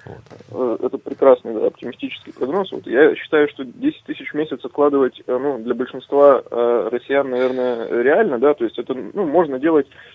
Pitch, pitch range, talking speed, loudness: 145 Hz, 130-180 Hz, 160 wpm, -18 LUFS